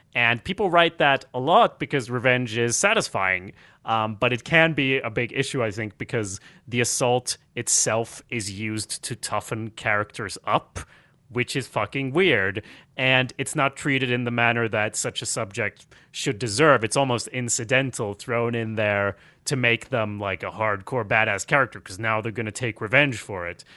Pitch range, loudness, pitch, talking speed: 110-135 Hz, -23 LUFS, 120 Hz, 175 wpm